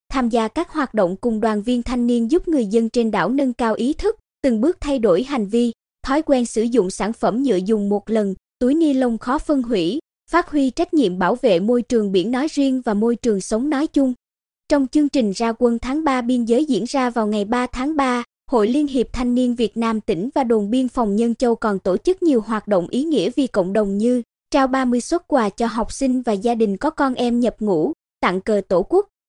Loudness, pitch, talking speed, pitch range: -19 LUFS, 245 Hz, 245 wpm, 225-275 Hz